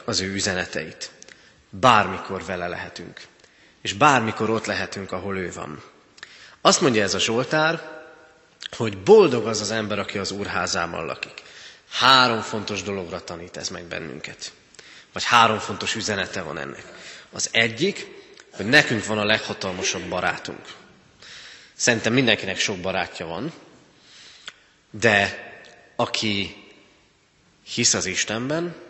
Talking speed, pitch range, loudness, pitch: 120 wpm, 95-120 Hz, -21 LUFS, 105 Hz